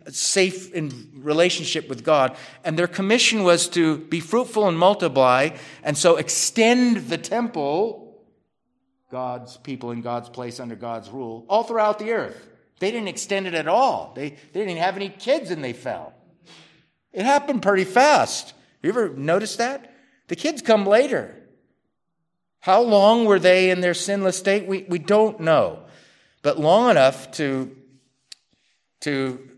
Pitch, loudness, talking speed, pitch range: 175 Hz, -20 LUFS, 150 wpm, 140-210 Hz